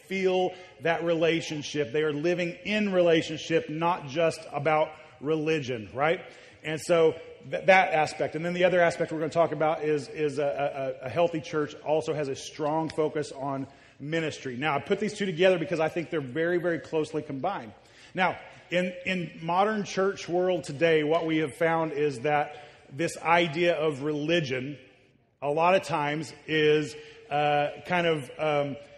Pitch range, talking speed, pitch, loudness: 145-170 Hz, 170 wpm, 155 Hz, -27 LUFS